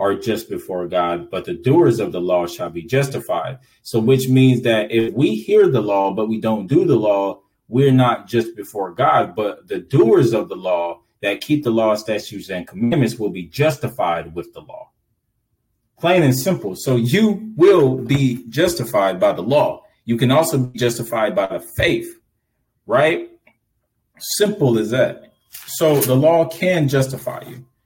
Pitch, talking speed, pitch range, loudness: 125 Hz, 175 wpm, 110-155 Hz, -18 LUFS